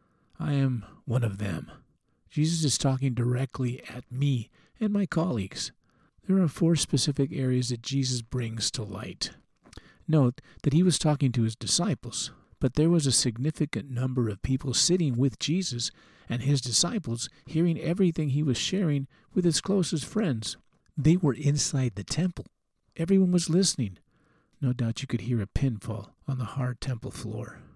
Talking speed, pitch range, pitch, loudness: 160 wpm, 120-160 Hz, 135 Hz, -28 LUFS